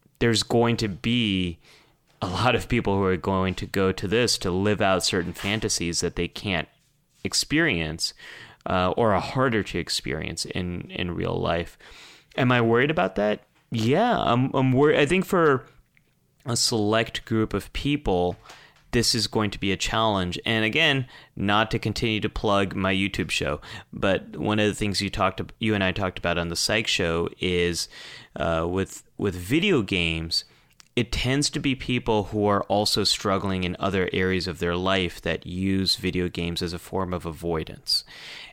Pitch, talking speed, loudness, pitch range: 100 Hz, 180 wpm, -24 LUFS, 90-115 Hz